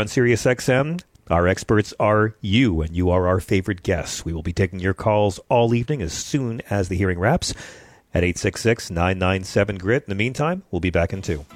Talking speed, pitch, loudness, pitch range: 200 wpm, 100 Hz, -21 LUFS, 90-115 Hz